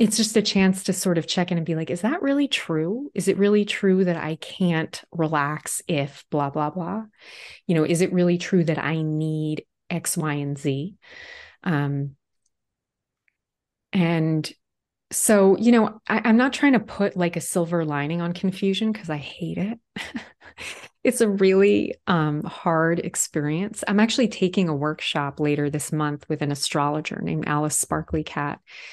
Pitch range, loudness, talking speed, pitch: 155-200 Hz, -23 LUFS, 170 wpm, 175 Hz